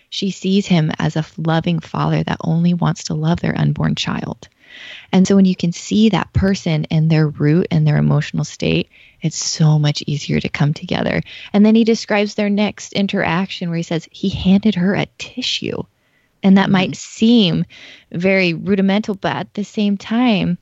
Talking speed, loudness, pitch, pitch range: 185 wpm, -17 LUFS, 180 Hz, 160-200 Hz